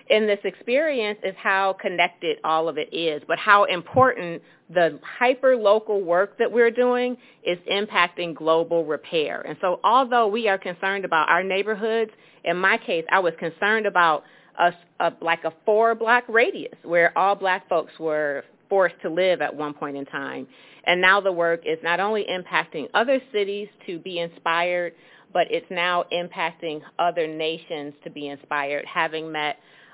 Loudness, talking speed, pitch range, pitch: -22 LUFS, 170 wpm, 165-210 Hz, 175 Hz